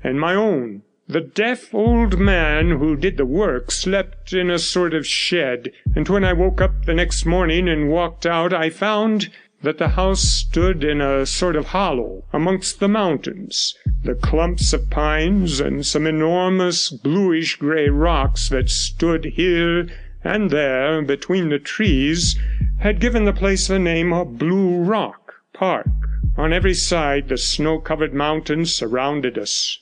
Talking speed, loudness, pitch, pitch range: 155 wpm, -19 LUFS, 165 Hz, 150-185 Hz